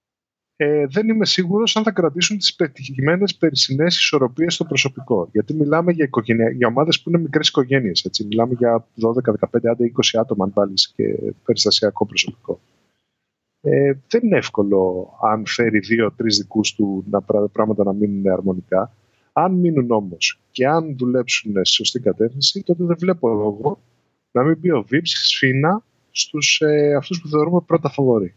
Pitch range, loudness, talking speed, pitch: 110-160 Hz, -18 LUFS, 160 wpm, 130 Hz